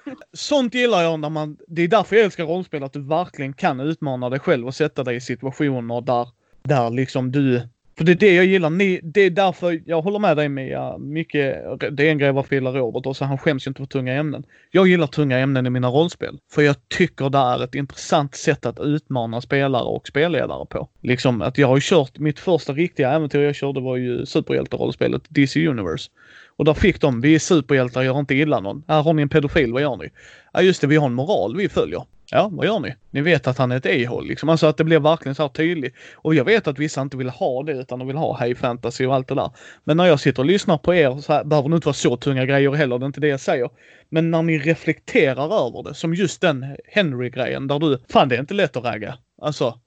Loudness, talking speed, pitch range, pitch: -20 LUFS, 250 wpm, 135-165 Hz, 145 Hz